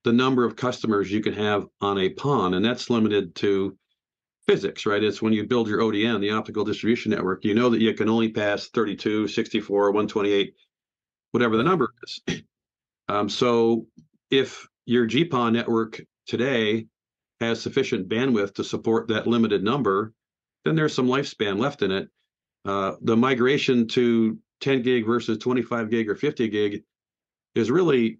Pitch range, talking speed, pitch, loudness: 105-120 Hz, 160 wpm, 115 Hz, -23 LUFS